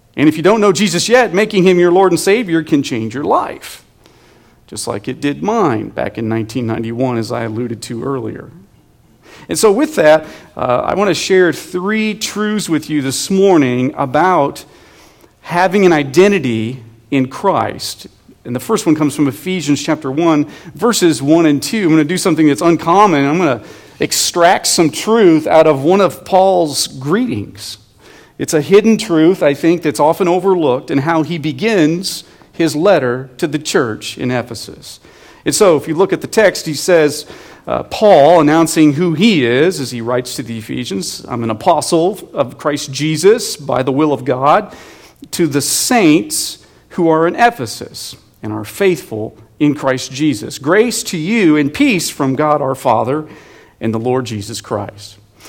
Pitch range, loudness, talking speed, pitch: 130-180 Hz, -13 LUFS, 175 wpm, 155 Hz